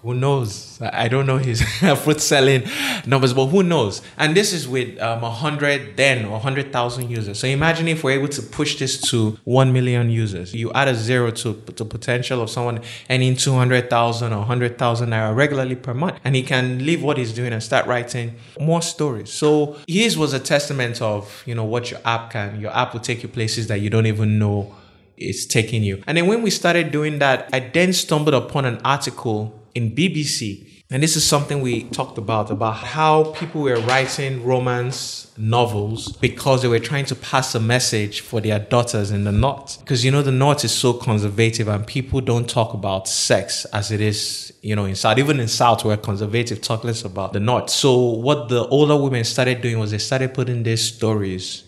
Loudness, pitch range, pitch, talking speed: -19 LUFS, 110-135 Hz, 125 Hz, 205 wpm